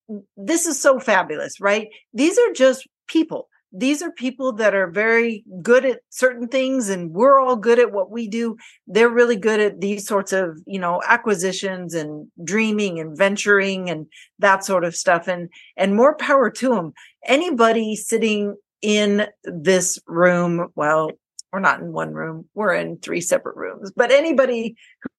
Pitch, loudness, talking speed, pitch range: 210 Hz, -19 LUFS, 170 wpm, 185-245 Hz